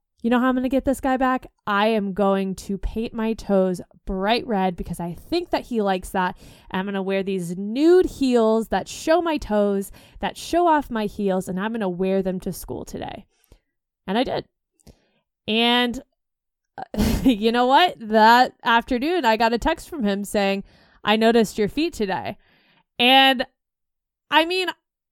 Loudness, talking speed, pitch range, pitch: -21 LUFS, 185 wpm, 195-260 Hz, 225 Hz